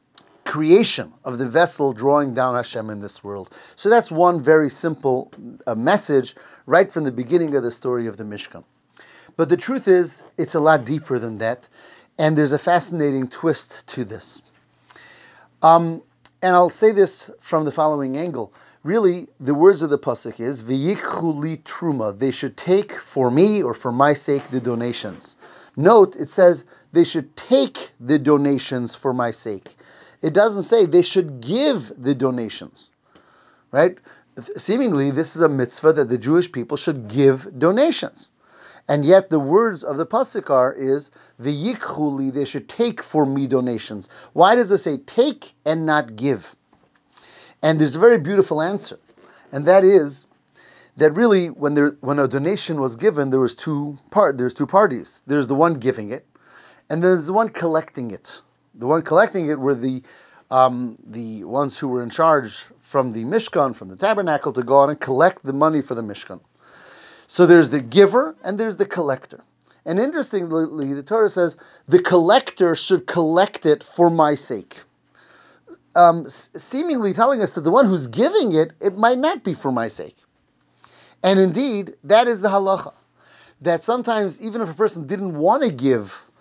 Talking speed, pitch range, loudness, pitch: 170 wpm, 135-185 Hz, -19 LUFS, 155 Hz